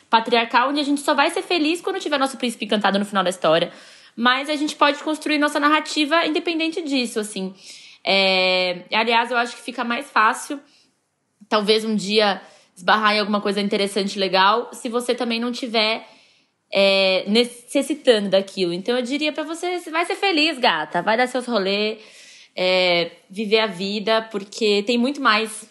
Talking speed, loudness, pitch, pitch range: 175 wpm, -20 LUFS, 230 Hz, 205-285 Hz